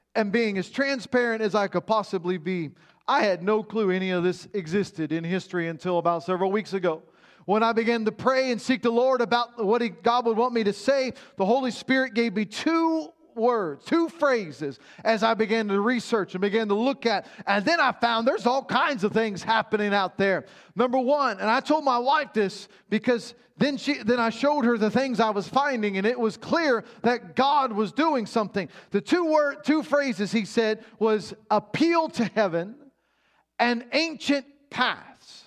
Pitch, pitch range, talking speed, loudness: 225 Hz, 200-260 Hz, 195 wpm, -25 LUFS